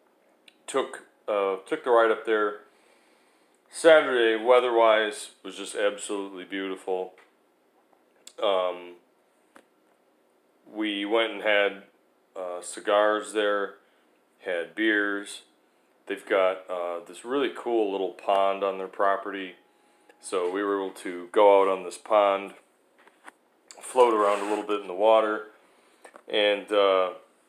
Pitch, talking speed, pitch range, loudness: 100 Hz, 120 wpm, 95-105 Hz, -25 LUFS